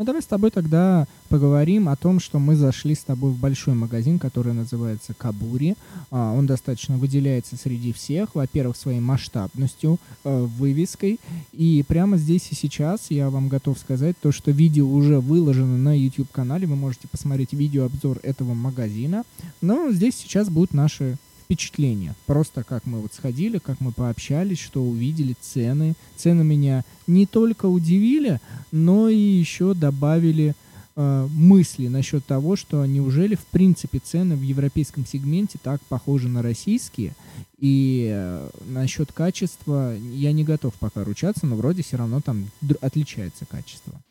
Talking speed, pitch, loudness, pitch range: 150 wpm, 140 Hz, -22 LUFS, 130-165 Hz